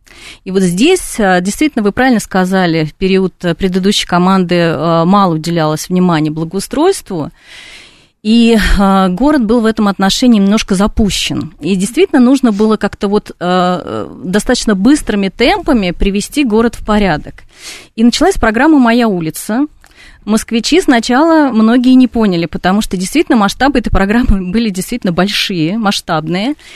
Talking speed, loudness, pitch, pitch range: 125 wpm, -11 LUFS, 210 Hz, 185-245 Hz